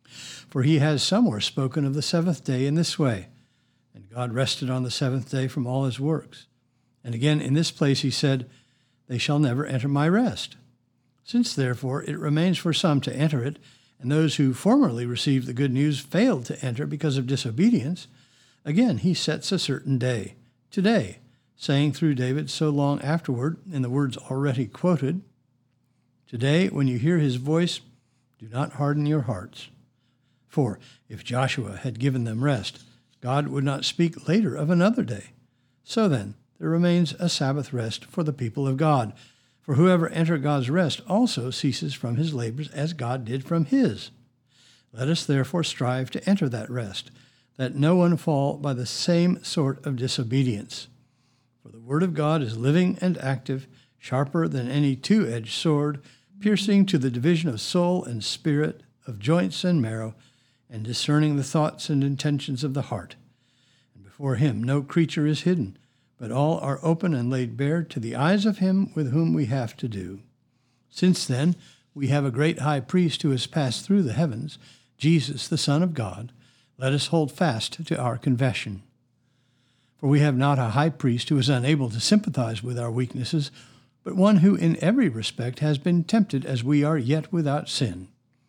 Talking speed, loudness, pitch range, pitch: 180 wpm, -24 LUFS, 125-155 Hz, 135 Hz